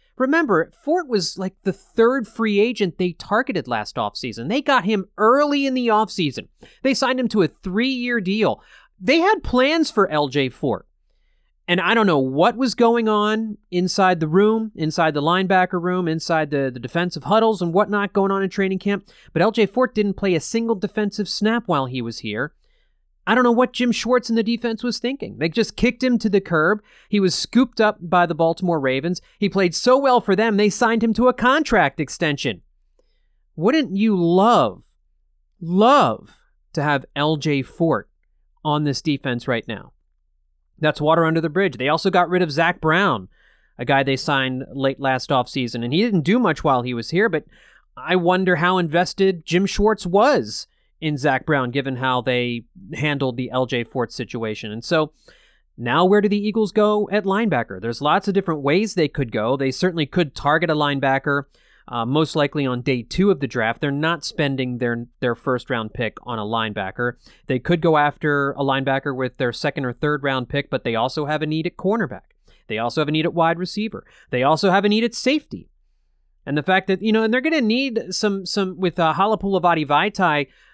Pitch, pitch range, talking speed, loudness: 175 Hz, 140-210 Hz, 200 wpm, -20 LUFS